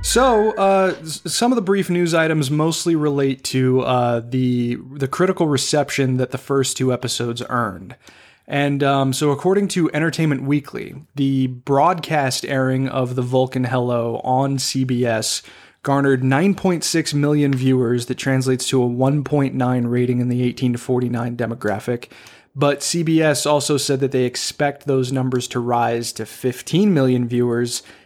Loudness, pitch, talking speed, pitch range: -19 LUFS, 135 Hz, 160 wpm, 125-150 Hz